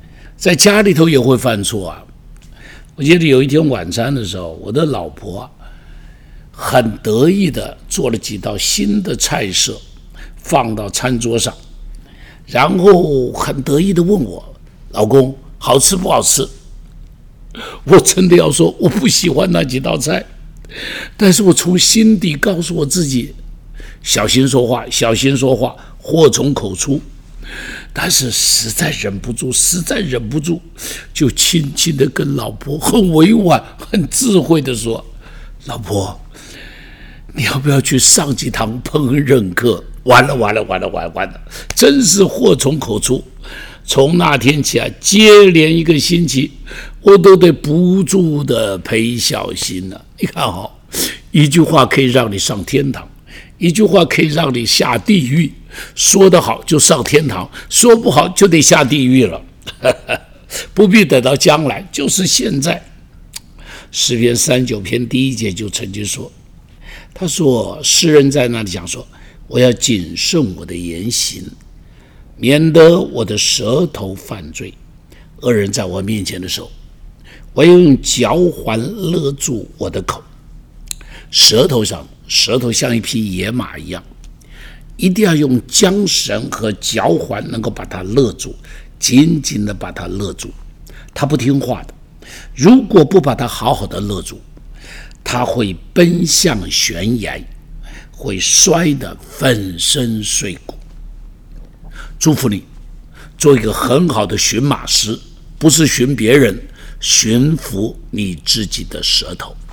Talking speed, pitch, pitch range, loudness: 200 characters per minute, 130 Hz, 110-165 Hz, -12 LUFS